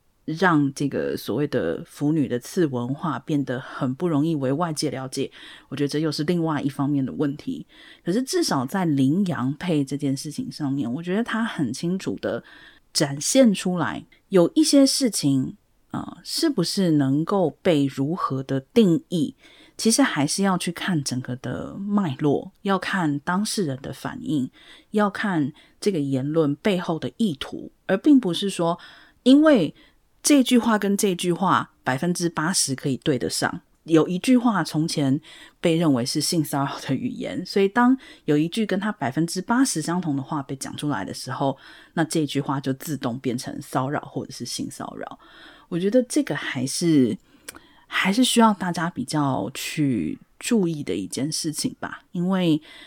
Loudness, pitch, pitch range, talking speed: -23 LUFS, 160 Hz, 140-205 Hz, 250 characters per minute